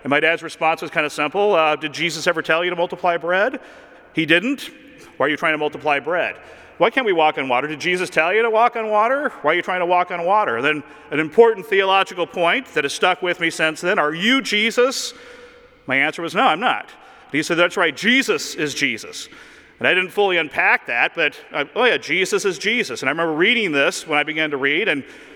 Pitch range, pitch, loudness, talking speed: 160-225 Hz, 175 Hz, -18 LUFS, 240 wpm